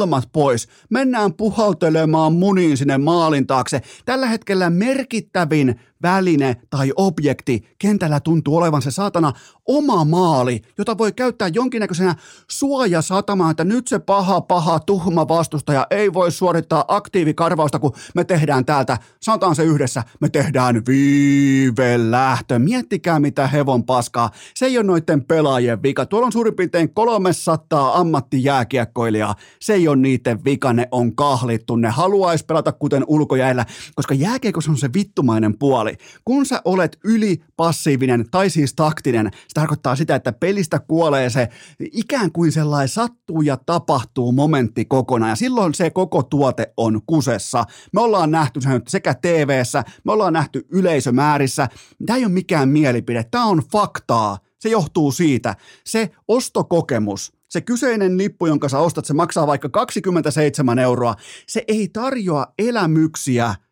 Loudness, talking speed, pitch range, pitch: -18 LUFS, 140 wpm, 135-185 Hz, 155 Hz